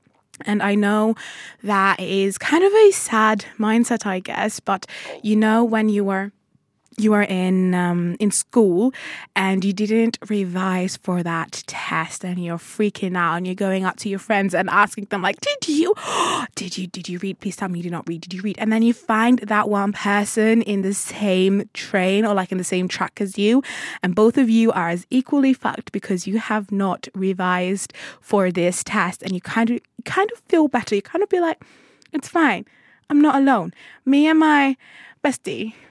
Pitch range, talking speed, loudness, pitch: 190-235 Hz, 200 wpm, -20 LUFS, 205 Hz